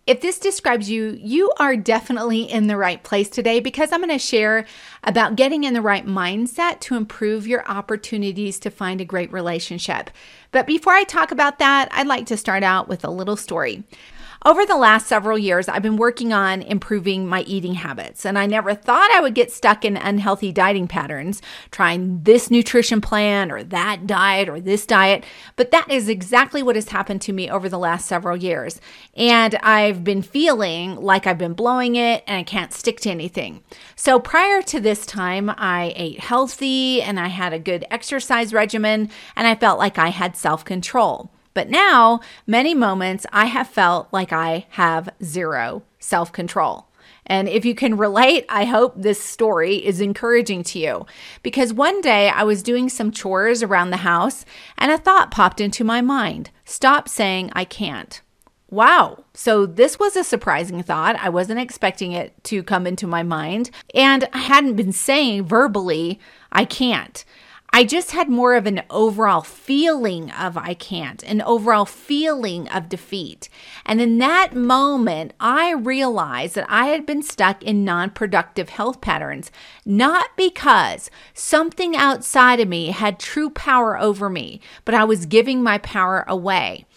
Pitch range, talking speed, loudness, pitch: 190-250 Hz, 175 wpm, -18 LUFS, 215 Hz